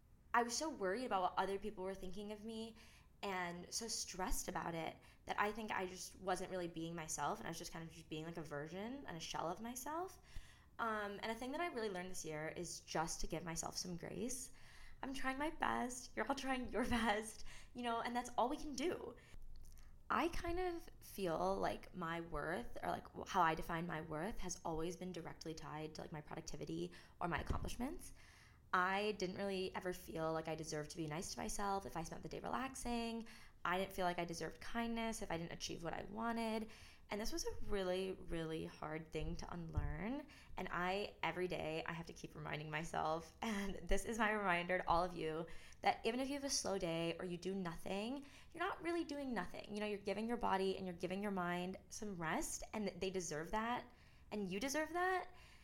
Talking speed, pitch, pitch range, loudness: 220 wpm, 190 Hz, 165-230 Hz, -43 LUFS